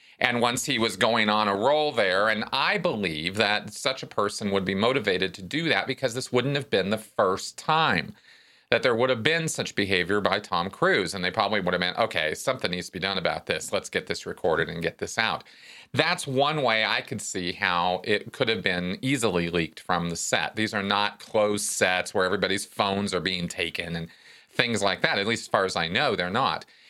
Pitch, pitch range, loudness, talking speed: 105 Hz, 95-130 Hz, -25 LUFS, 230 wpm